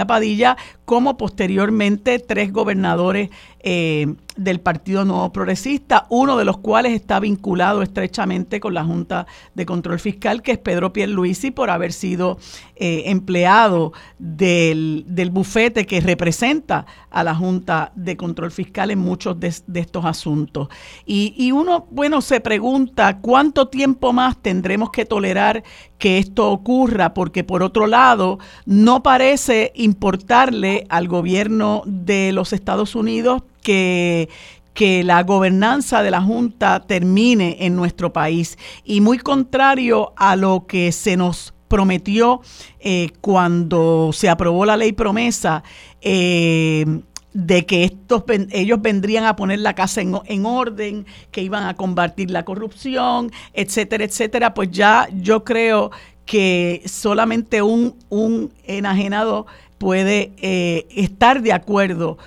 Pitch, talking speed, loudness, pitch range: 200 Hz, 135 wpm, -17 LUFS, 180-225 Hz